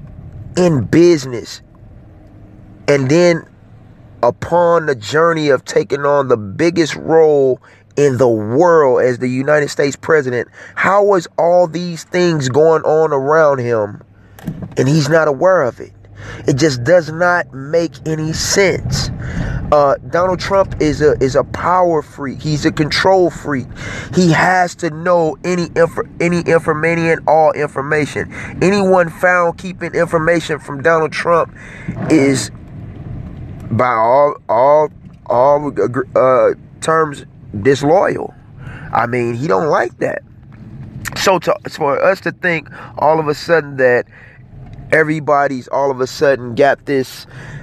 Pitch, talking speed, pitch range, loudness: 150 Hz, 130 wpm, 130-170 Hz, -14 LUFS